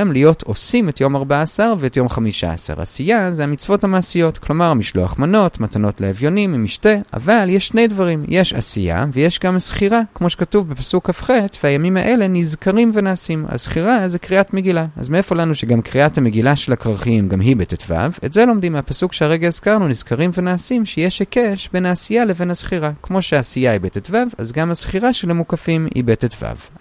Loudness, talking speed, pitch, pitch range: -16 LUFS, 170 wpm, 170 Hz, 135-195 Hz